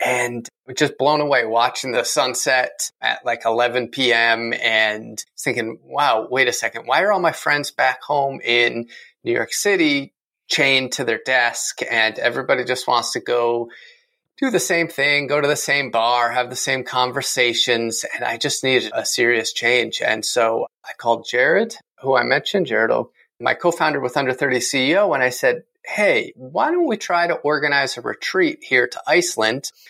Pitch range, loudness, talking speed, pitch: 120-150 Hz, -19 LUFS, 180 wpm, 135 Hz